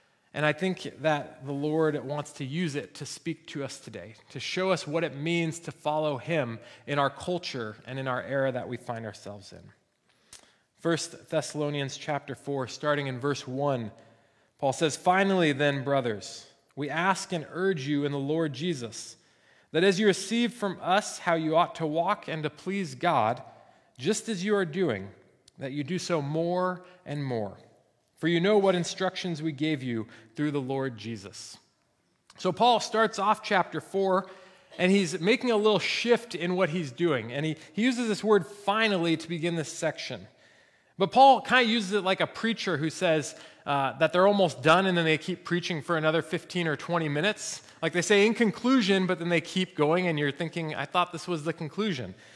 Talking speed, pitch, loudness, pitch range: 195 wpm, 165 Hz, -28 LUFS, 145-185 Hz